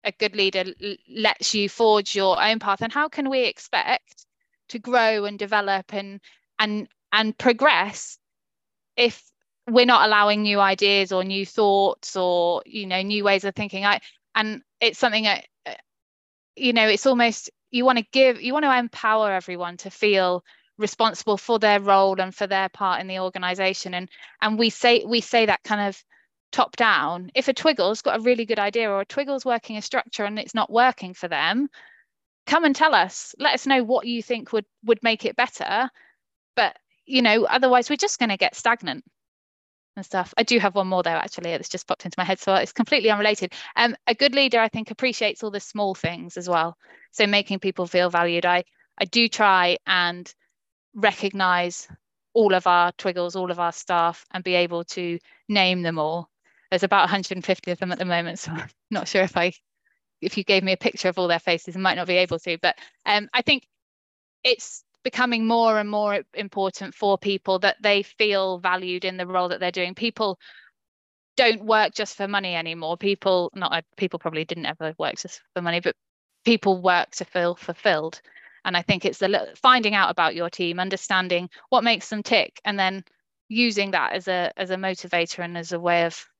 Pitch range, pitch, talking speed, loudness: 180-230 Hz, 200 Hz, 200 wpm, -22 LUFS